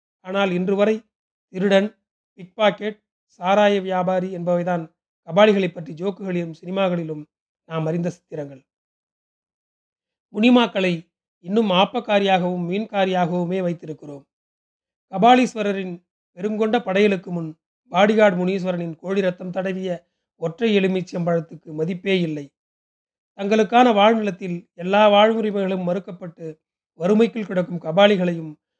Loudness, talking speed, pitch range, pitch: -20 LUFS, 85 wpm, 175-205 Hz, 185 Hz